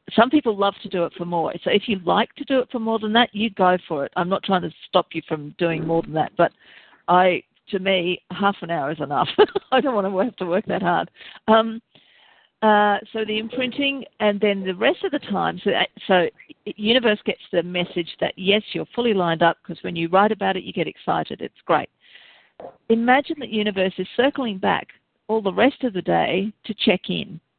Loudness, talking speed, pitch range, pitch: -21 LUFS, 220 wpm, 180-225 Hz, 205 Hz